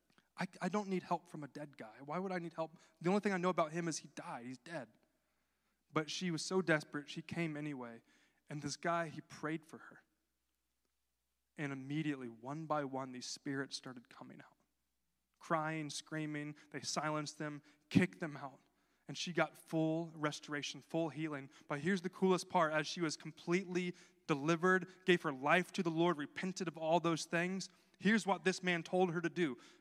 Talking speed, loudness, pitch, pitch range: 190 wpm, -39 LUFS, 160 Hz, 145-180 Hz